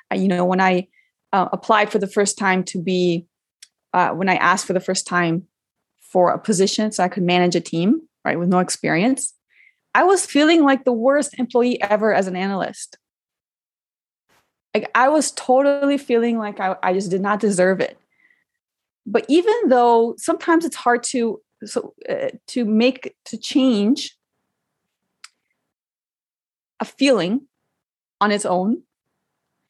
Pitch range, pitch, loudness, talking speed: 190-275 Hz, 225 Hz, -19 LUFS, 150 wpm